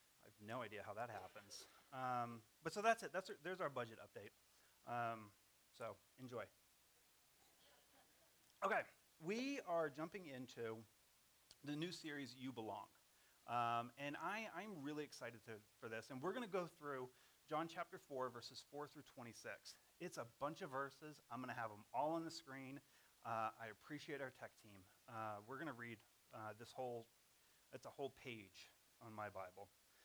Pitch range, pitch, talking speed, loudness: 115-150 Hz, 130 Hz, 175 wpm, -50 LUFS